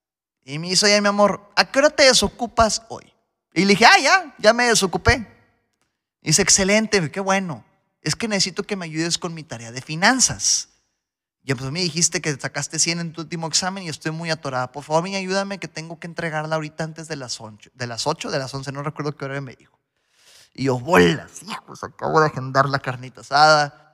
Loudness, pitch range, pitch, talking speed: -19 LUFS, 145-195 Hz, 165 Hz, 220 wpm